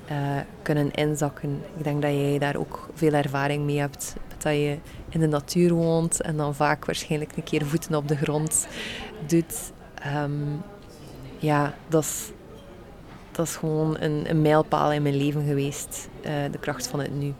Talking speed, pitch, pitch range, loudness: 165 wpm, 150 Hz, 145-155 Hz, -26 LUFS